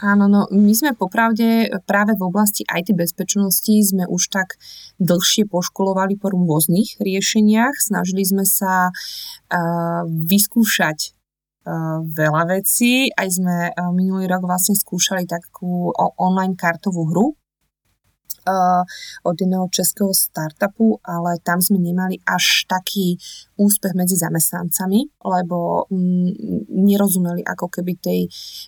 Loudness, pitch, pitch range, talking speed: -18 LUFS, 185 Hz, 175-200 Hz, 120 wpm